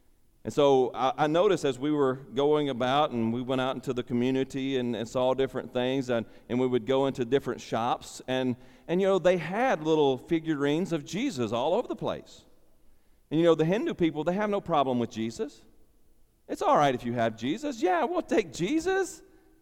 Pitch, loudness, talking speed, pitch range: 135 Hz, -28 LUFS, 205 wpm, 125-165 Hz